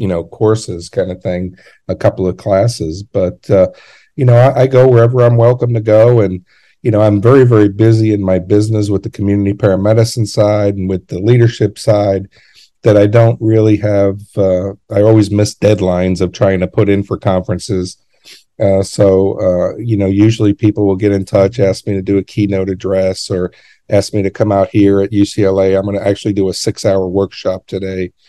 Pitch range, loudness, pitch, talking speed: 95-110 Hz, -12 LUFS, 100 Hz, 205 wpm